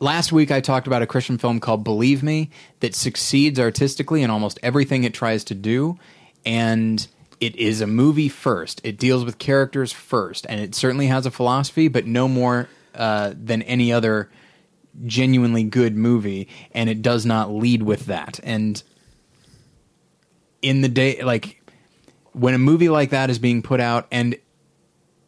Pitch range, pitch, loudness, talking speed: 115-135 Hz, 125 Hz, -20 LUFS, 165 wpm